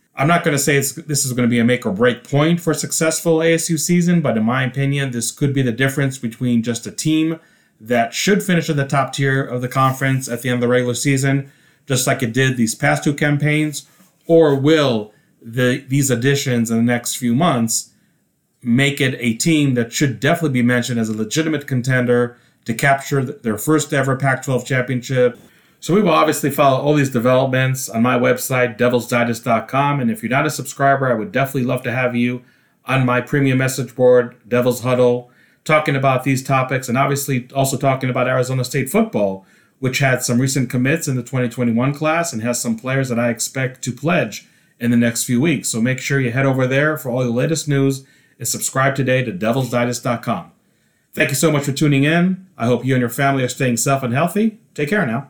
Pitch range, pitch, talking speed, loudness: 125-145 Hz, 130 Hz, 210 wpm, -17 LUFS